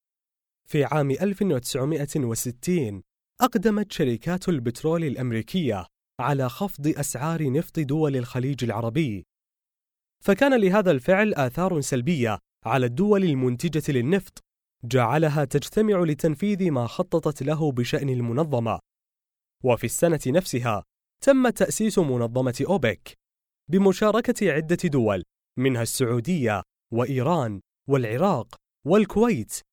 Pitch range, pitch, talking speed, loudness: 125-180 Hz, 150 Hz, 95 wpm, -24 LUFS